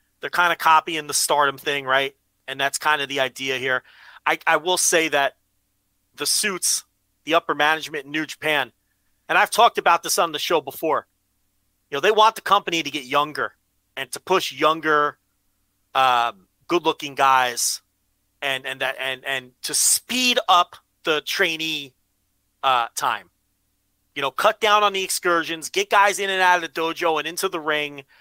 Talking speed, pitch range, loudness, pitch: 180 wpm, 100-165 Hz, -21 LUFS, 140 Hz